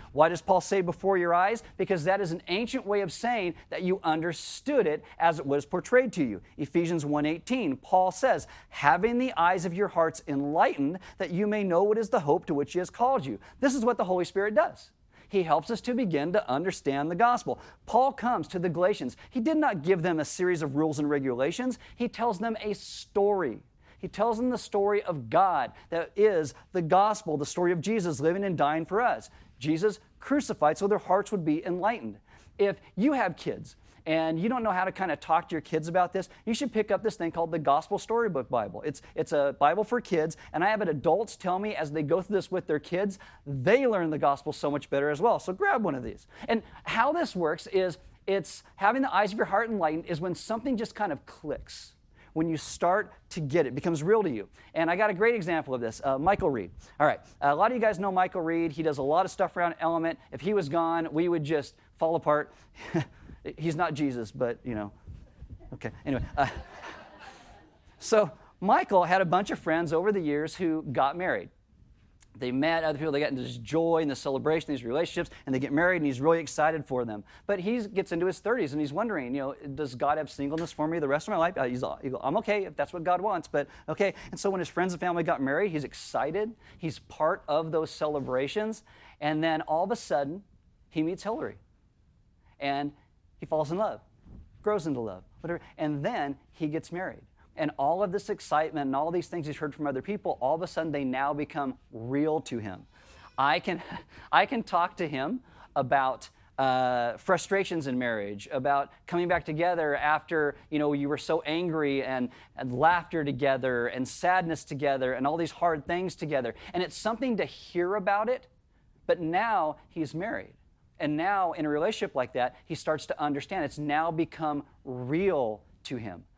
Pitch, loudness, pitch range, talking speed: 165 Hz, -29 LUFS, 145-195 Hz, 215 wpm